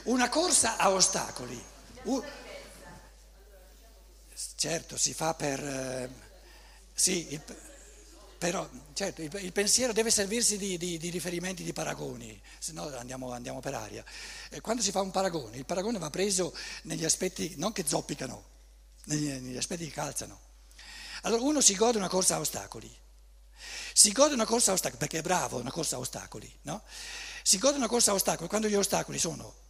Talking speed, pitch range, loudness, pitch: 170 wpm, 145-215 Hz, -29 LUFS, 180 Hz